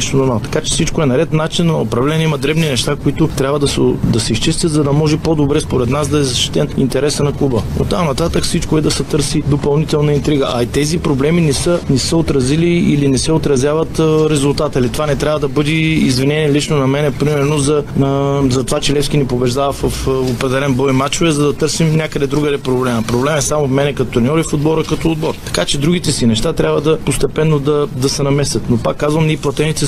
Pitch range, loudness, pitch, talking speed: 135-155 Hz, -14 LUFS, 145 Hz, 230 wpm